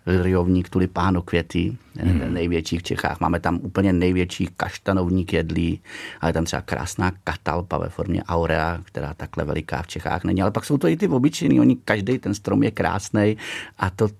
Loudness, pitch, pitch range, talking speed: -23 LUFS, 90 Hz, 85-100 Hz, 180 wpm